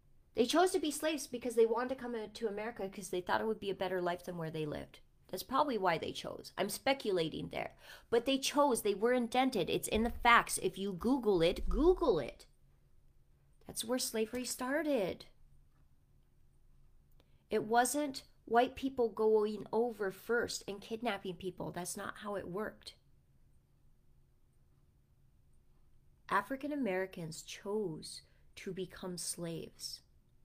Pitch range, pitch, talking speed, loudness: 190-250 Hz, 220 Hz, 145 wpm, -35 LUFS